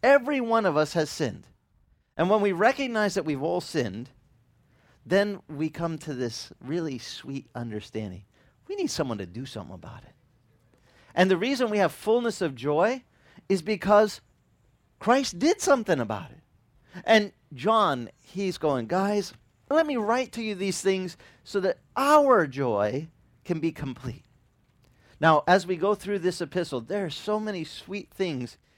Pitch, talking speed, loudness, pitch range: 165 Hz, 160 wpm, -26 LUFS, 130-205 Hz